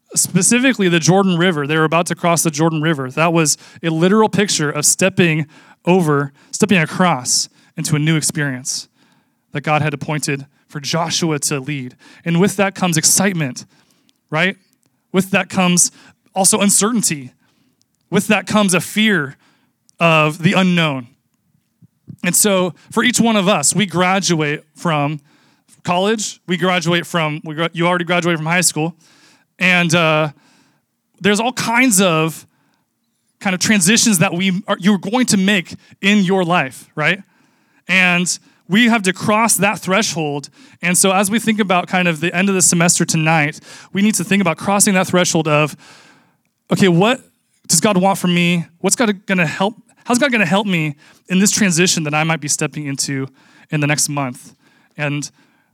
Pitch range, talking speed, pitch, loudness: 155-200 Hz, 165 wpm, 180 Hz, -15 LUFS